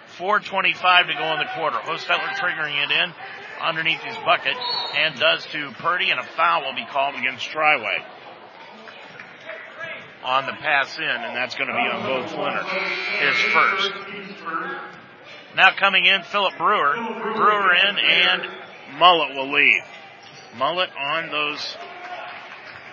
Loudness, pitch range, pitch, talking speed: -20 LUFS, 180-210 Hz, 195 Hz, 140 wpm